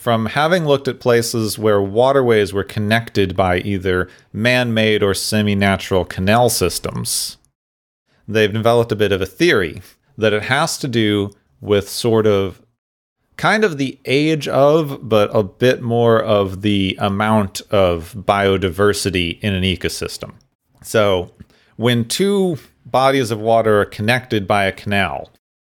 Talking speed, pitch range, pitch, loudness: 140 wpm, 100-120 Hz, 105 Hz, -17 LUFS